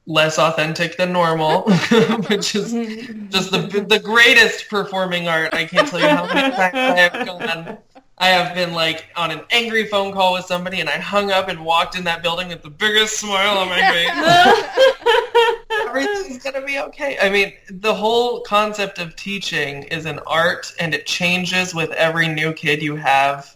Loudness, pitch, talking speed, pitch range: -17 LUFS, 190 Hz, 185 wpm, 170-230 Hz